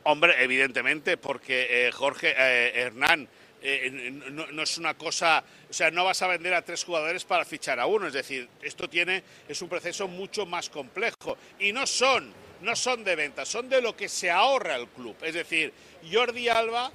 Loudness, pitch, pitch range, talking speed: -26 LUFS, 165 Hz, 135-185 Hz, 200 wpm